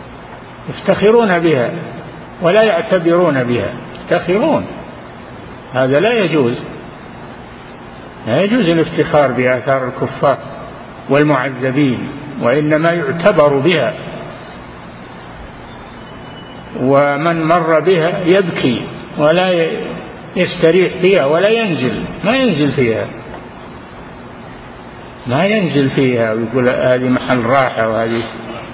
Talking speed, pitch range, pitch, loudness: 80 wpm, 125-170 Hz, 145 Hz, -14 LUFS